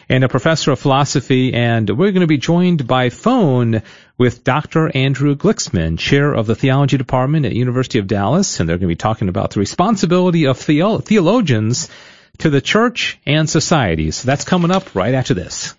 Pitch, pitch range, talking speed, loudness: 140 Hz, 120-165 Hz, 185 wpm, -15 LUFS